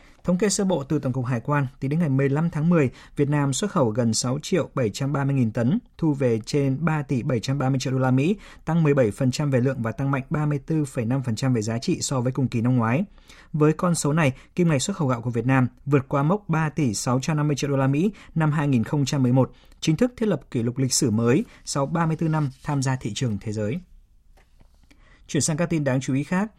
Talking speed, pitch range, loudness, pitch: 230 wpm, 130-160 Hz, -23 LUFS, 140 Hz